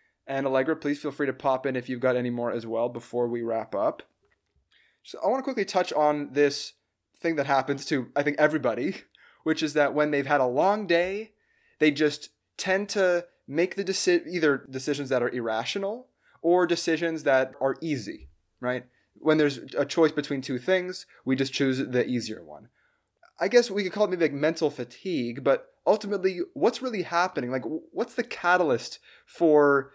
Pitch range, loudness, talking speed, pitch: 130-180 Hz, -26 LUFS, 190 wpm, 145 Hz